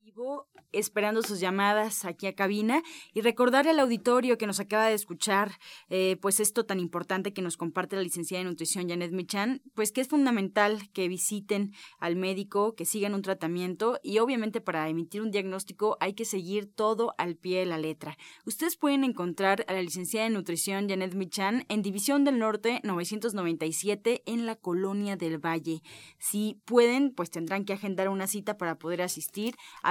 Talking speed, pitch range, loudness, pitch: 175 wpm, 185-225 Hz, -29 LUFS, 200 Hz